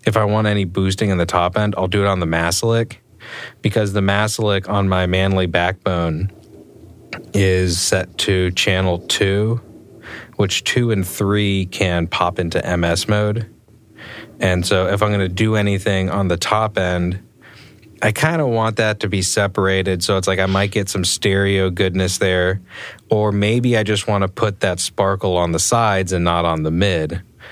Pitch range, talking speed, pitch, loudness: 90-105 Hz, 175 wpm, 100 Hz, -18 LUFS